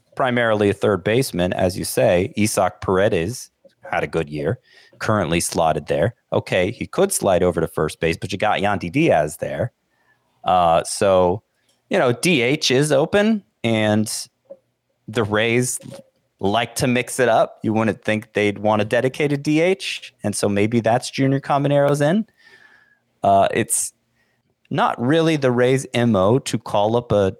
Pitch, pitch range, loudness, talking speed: 120 Hz, 105-145 Hz, -19 LUFS, 155 wpm